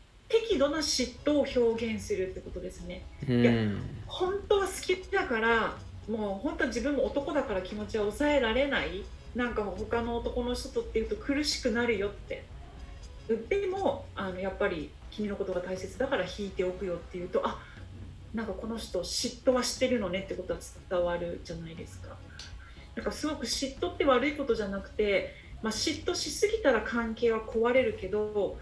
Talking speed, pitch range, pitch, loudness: 350 characters per minute, 185-275 Hz, 225 Hz, -31 LUFS